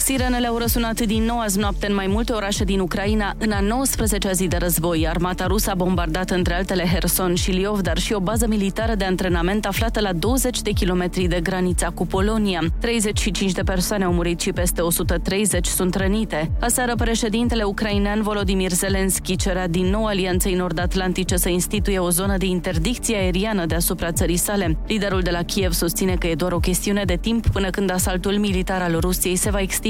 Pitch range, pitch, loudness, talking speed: 180-210 Hz, 195 Hz, -21 LUFS, 190 wpm